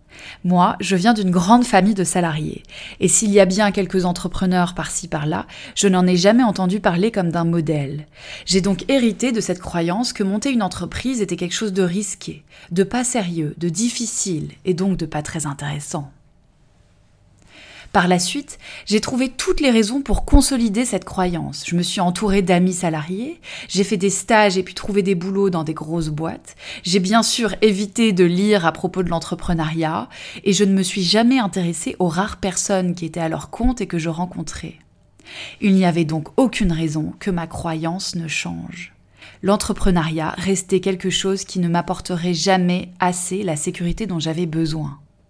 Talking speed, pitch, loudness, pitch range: 185 wpm, 185 Hz, -19 LUFS, 165-205 Hz